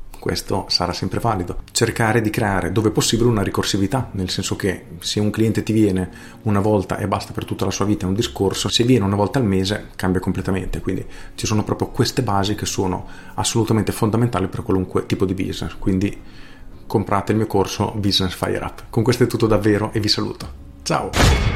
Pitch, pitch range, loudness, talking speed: 100 Hz, 95-110 Hz, -20 LUFS, 200 wpm